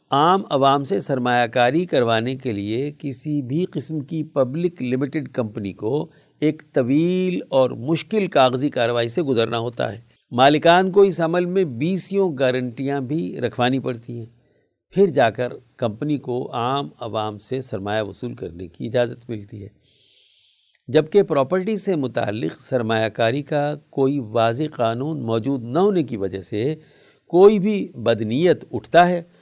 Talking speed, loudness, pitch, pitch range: 150 wpm, -21 LUFS, 135 Hz, 120-155 Hz